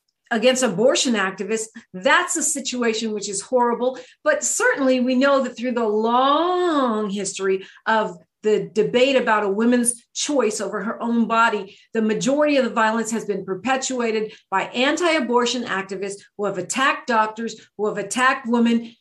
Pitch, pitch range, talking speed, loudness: 230 Hz, 210-255 Hz, 155 wpm, -20 LUFS